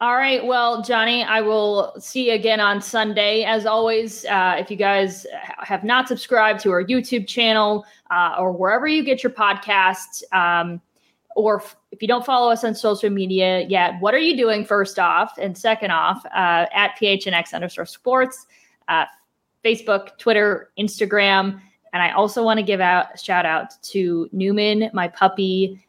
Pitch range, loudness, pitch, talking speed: 190-225 Hz, -19 LUFS, 210 Hz, 175 wpm